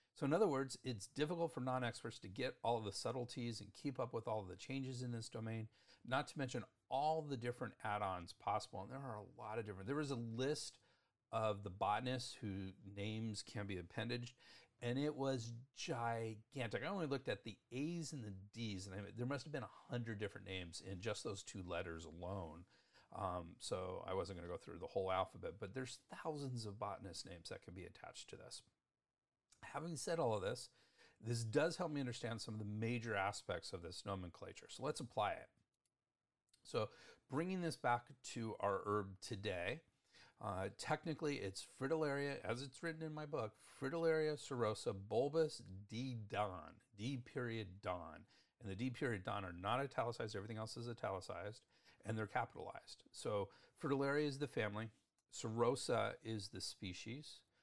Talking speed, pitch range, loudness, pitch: 185 wpm, 105-135 Hz, -45 LUFS, 120 Hz